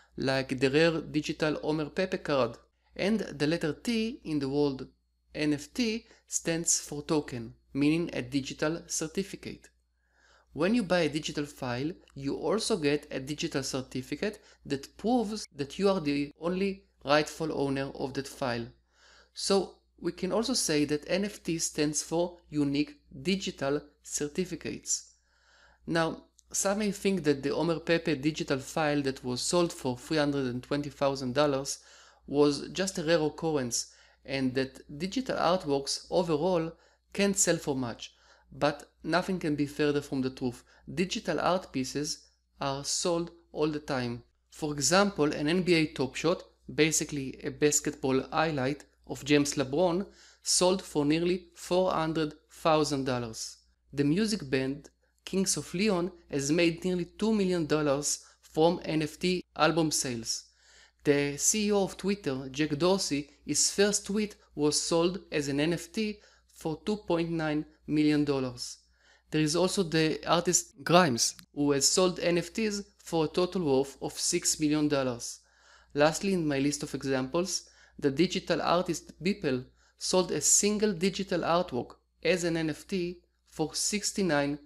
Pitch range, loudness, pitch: 140-180 Hz, -30 LUFS, 155 Hz